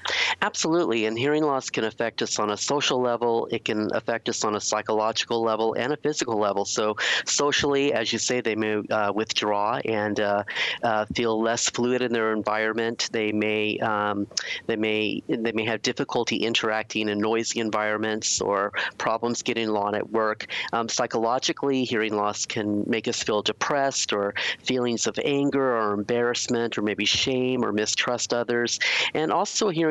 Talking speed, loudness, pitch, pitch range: 170 wpm, -24 LUFS, 115 Hz, 105-125 Hz